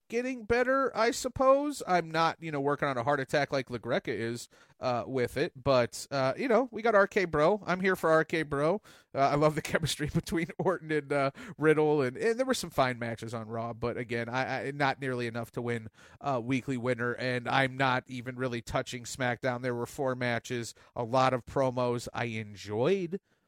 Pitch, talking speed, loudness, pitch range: 135 Hz, 205 wpm, -30 LUFS, 125-170 Hz